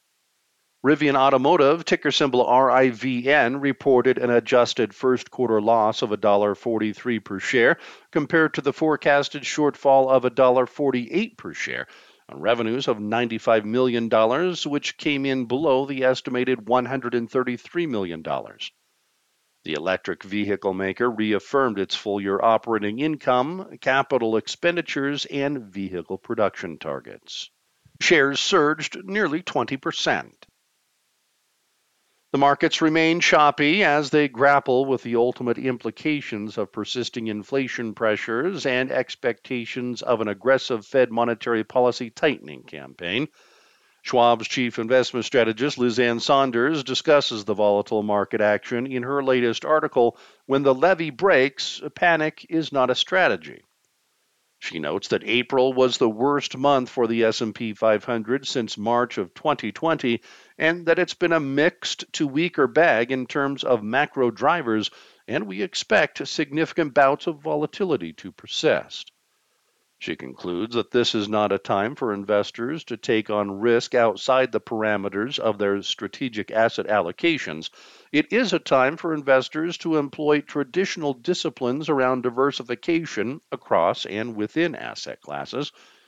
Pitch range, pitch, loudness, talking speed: 115-150 Hz, 130 Hz, -22 LUFS, 130 wpm